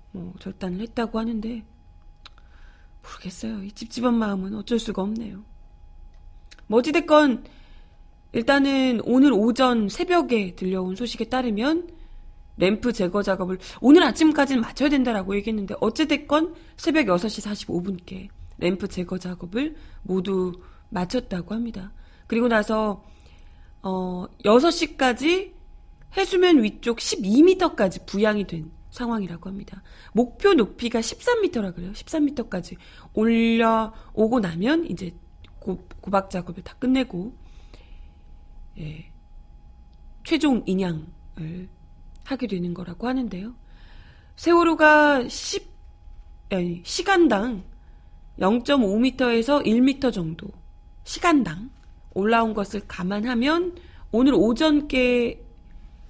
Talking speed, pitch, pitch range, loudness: 230 characters per minute, 220 Hz, 185-255 Hz, -22 LUFS